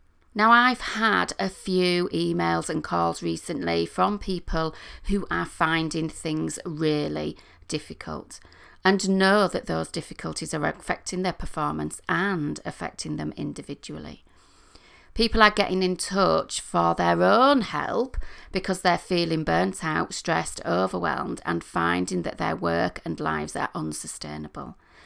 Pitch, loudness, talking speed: 165 Hz, -25 LUFS, 130 wpm